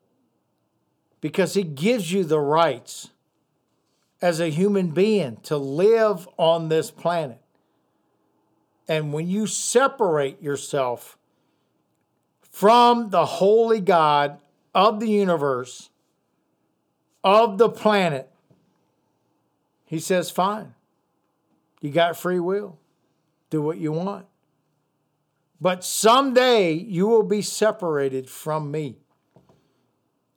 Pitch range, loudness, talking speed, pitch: 155-200 Hz, -21 LUFS, 95 wpm, 170 Hz